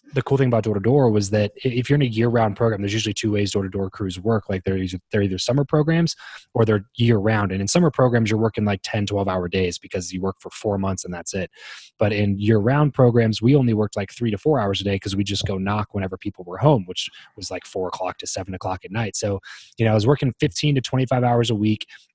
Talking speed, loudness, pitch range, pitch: 255 wpm, -21 LUFS, 100-120 Hz, 105 Hz